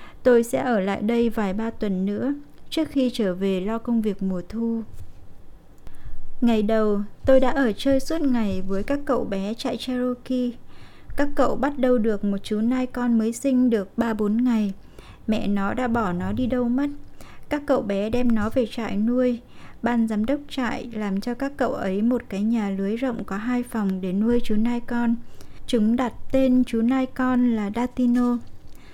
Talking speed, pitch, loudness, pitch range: 190 wpm, 235 Hz, -24 LUFS, 210-250 Hz